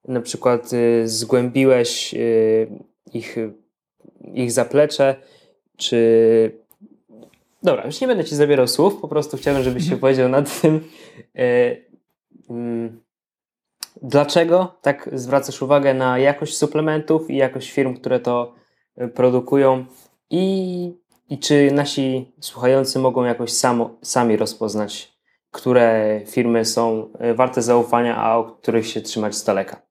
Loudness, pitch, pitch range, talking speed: -19 LUFS, 130 Hz, 115-145 Hz, 115 wpm